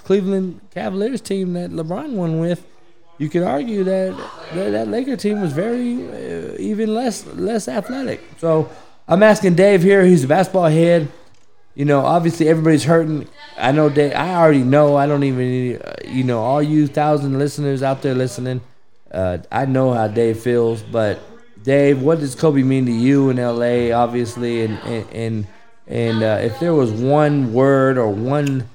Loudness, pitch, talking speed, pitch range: -17 LUFS, 145 Hz, 170 wpm, 125-175 Hz